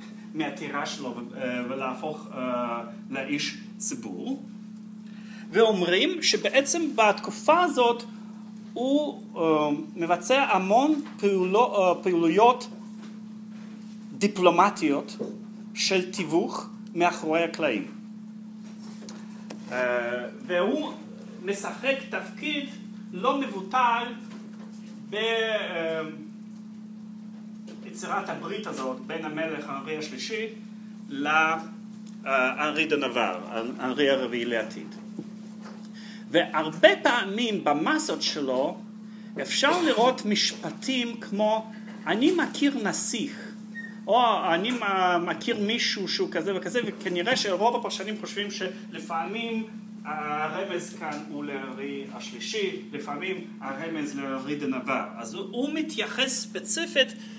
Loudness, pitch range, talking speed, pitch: -26 LUFS, 190-225 Hz, 75 wpm, 215 Hz